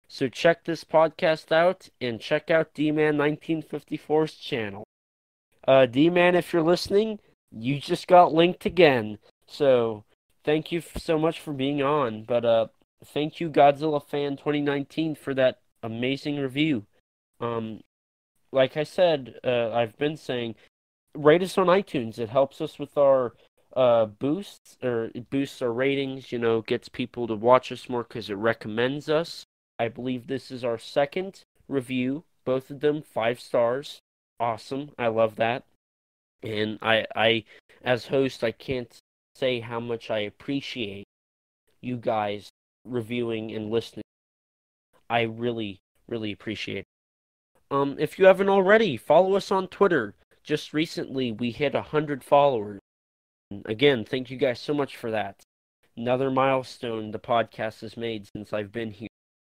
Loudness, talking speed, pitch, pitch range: -25 LUFS, 150 wpm, 130 Hz, 110-150 Hz